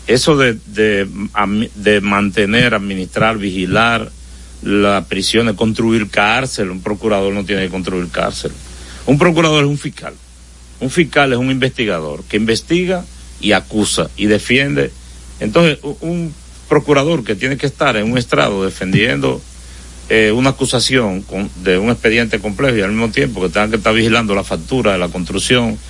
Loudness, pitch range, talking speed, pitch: -14 LUFS, 95-130 Hz, 160 wpm, 105 Hz